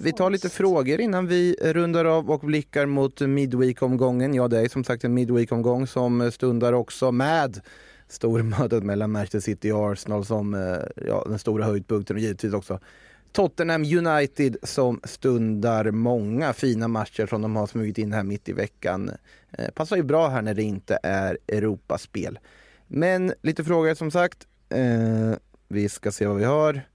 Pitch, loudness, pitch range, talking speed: 120 Hz, -24 LUFS, 110-150 Hz, 165 wpm